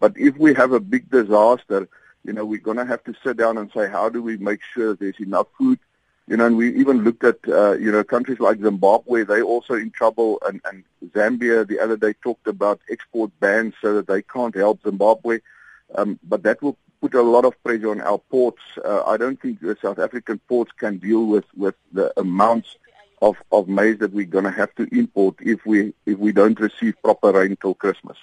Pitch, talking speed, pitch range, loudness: 110 Hz, 225 wpm, 105-120 Hz, -20 LUFS